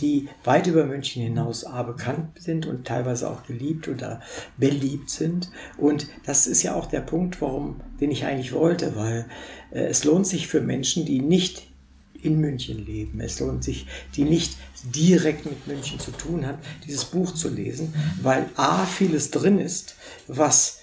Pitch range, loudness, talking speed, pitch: 130-160 Hz, -24 LUFS, 175 wpm, 145 Hz